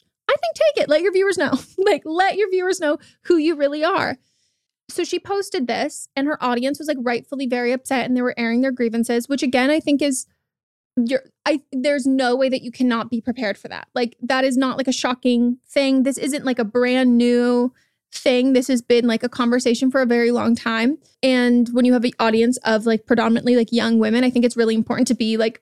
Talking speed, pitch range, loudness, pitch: 230 wpm, 240-280 Hz, -19 LUFS, 250 Hz